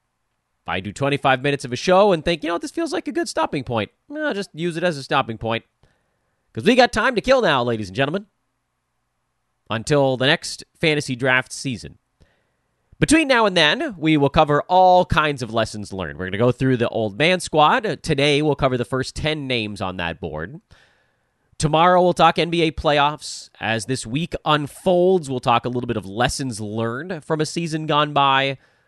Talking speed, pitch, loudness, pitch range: 200 wpm, 140 Hz, -20 LUFS, 115-170 Hz